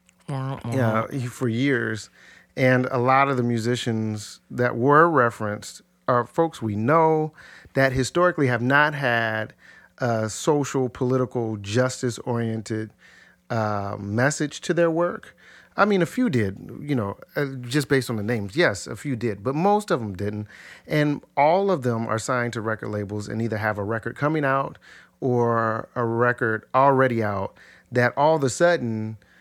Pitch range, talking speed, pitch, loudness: 110-140 Hz, 160 wpm, 125 Hz, -23 LUFS